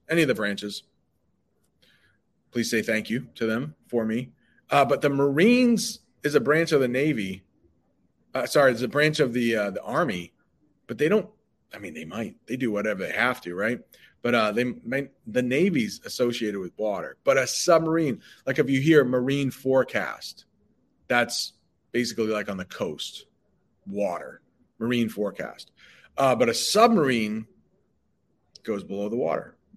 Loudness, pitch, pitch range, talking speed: -25 LUFS, 125 Hz, 110-150 Hz, 165 wpm